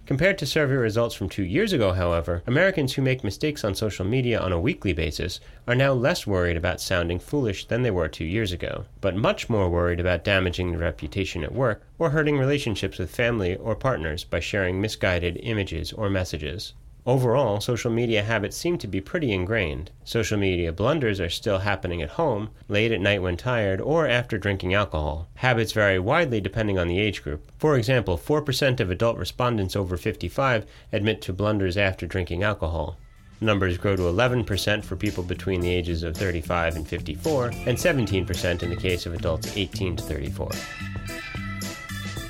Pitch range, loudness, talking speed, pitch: 90-115 Hz, -25 LUFS, 180 wpm, 100 Hz